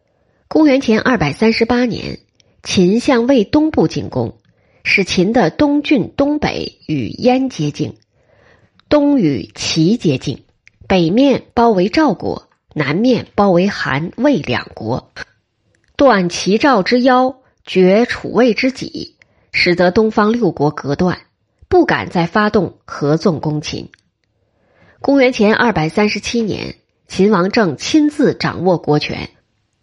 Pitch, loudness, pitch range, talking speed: 210 Hz, -14 LUFS, 170-255 Hz, 185 characters per minute